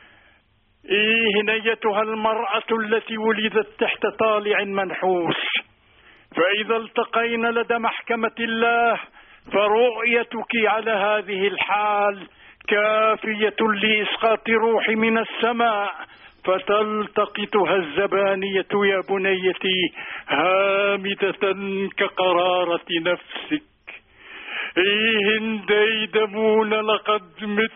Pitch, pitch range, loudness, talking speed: 215 Hz, 200-225 Hz, -21 LUFS, 70 wpm